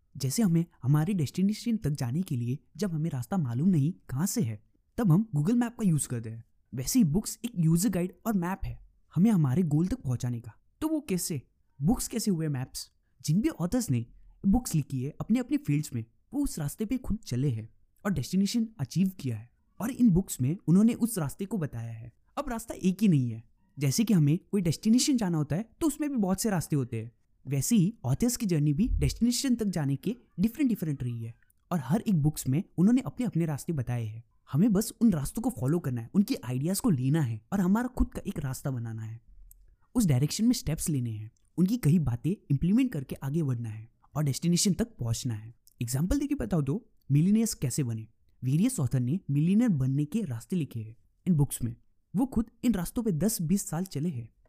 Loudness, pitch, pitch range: -29 LUFS, 160 Hz, 130-210 Hz